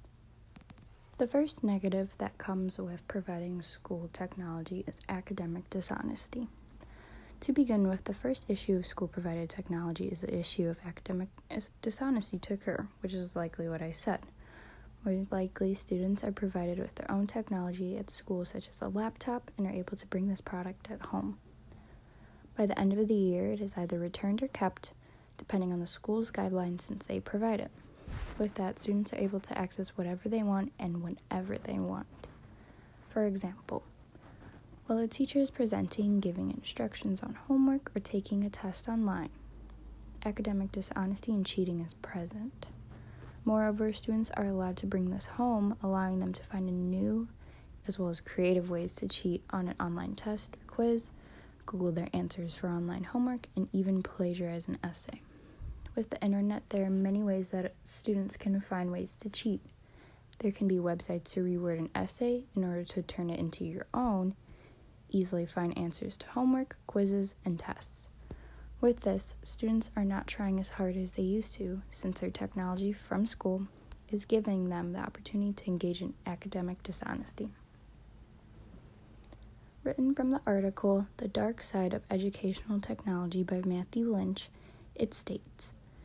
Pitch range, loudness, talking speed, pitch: 180-210 Hz, -35 LUFS, 165 wpm, 190 Hz